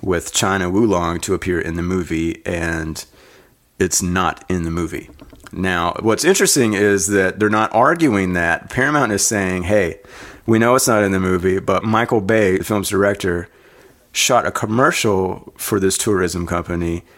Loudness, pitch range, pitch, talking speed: -17 LUFS, 85-105 Hz, 95 Hz, 165 wpm